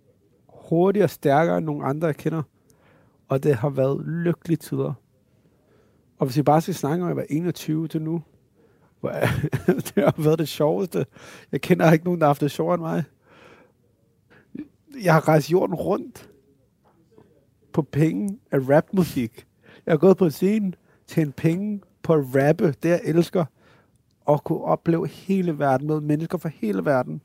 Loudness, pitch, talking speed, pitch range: -23 LUFS, 160 Hz, 165 wpm, 145-175 Hz